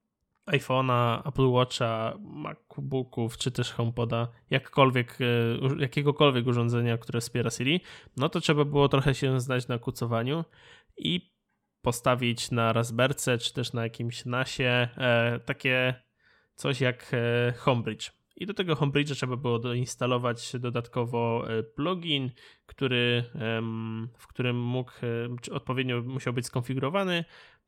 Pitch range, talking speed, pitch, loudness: 120-135 Hz, 115 wpm, 125 Hz, -28 LUFS